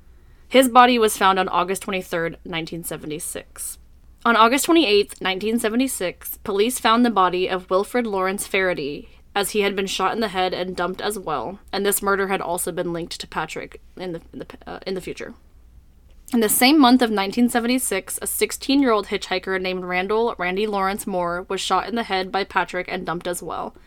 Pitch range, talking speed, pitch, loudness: 180-220 Hz, 190 wpm, 190 Hz, -21 LUFS